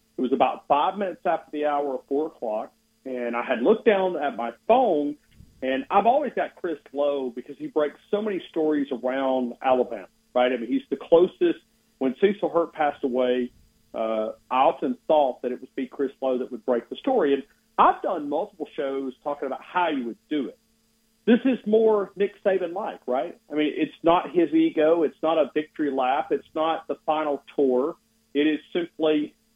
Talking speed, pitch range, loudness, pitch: 195 wpm, 130-170 Hz, -25 LUFS, 145 Hz